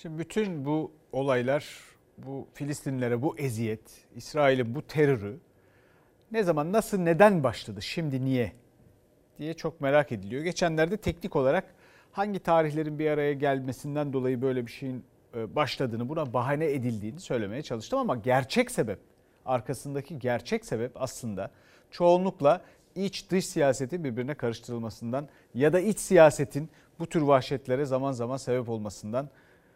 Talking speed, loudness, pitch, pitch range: 130 wpm, -28 LUFS, 140 Hz, 125-160 Hz